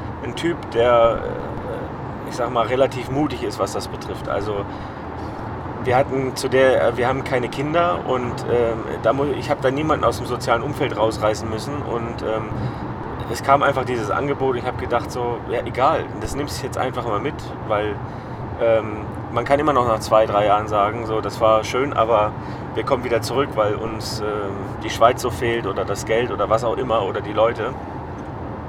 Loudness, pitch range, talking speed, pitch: -21 LUFS, 110-130 Hz, 195 wpm, 120 Hz